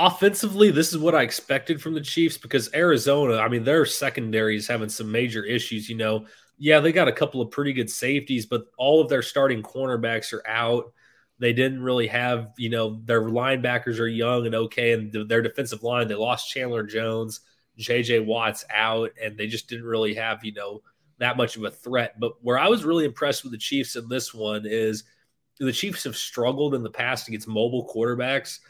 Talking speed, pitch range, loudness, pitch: 205 wpm, 110-135 Hz, -24 LUFS, 120 Hz